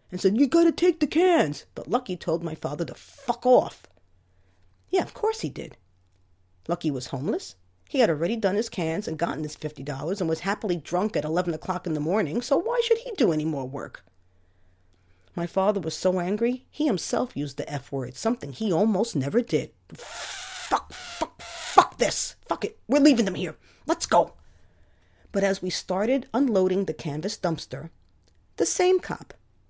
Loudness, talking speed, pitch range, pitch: -26 LUFS, 185 wpm, 135-225 Hz, 170 Hz